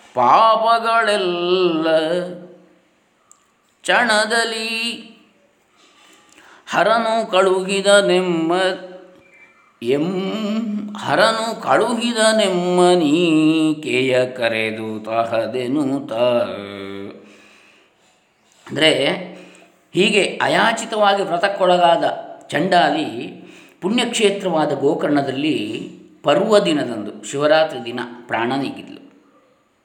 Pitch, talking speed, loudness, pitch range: 185 Hz, 45 wpm, -17 LUFS, 155-220 Hz